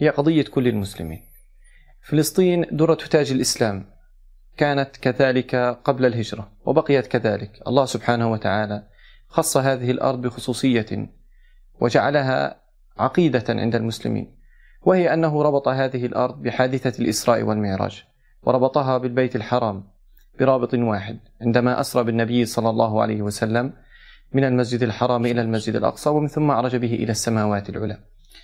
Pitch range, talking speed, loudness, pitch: 110-135 Hz, 120 wpm, -21 LUFS, 125 Hz